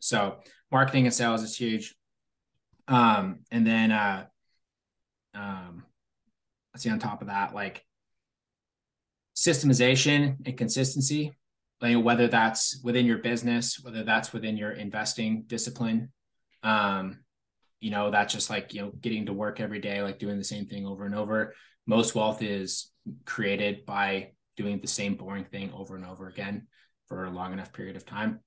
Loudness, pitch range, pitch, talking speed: -27 LUFS, 100-120 Hz, 110 Hz, 160 wpm